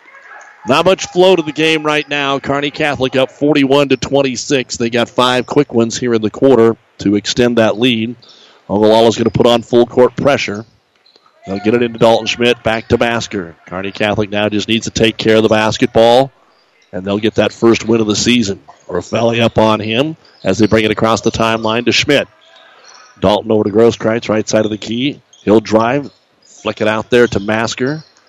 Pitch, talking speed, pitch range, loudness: 115 Hz, 200 wpm, 110-130 Hz, -13 LUFS